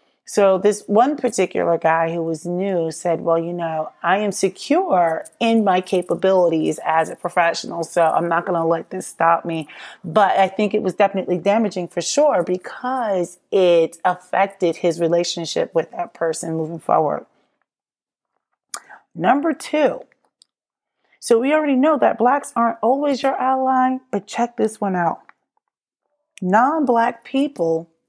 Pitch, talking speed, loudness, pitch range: 190 Hz, 145 wpm, -19 LUFS, 170-235 Hz